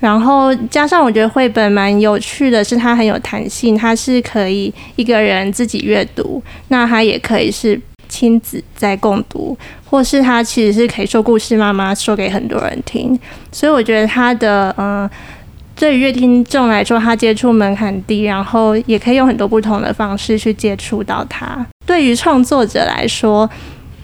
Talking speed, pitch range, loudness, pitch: 265 characters per minute, 210-250 Hz, -13 LUFS, 225 Hz